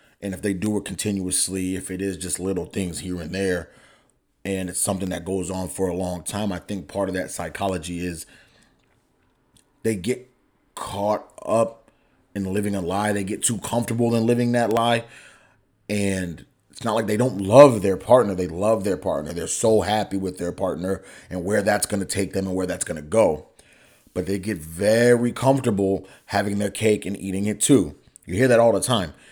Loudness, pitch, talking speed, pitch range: -23 LUFS, 100 Hz, 200 wpm, 95-110 Hz